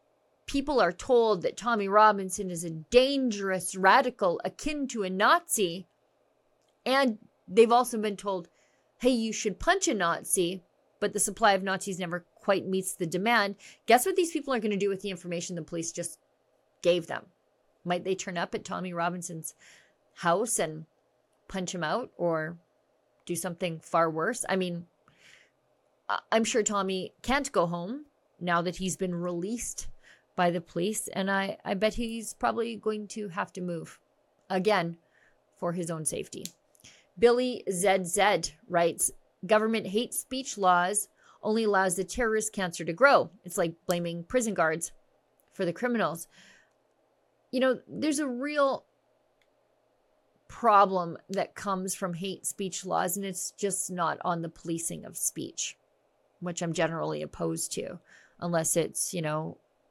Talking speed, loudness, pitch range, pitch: 150 wpm, -29 LUFS, 175-225 Hz, 190 Hz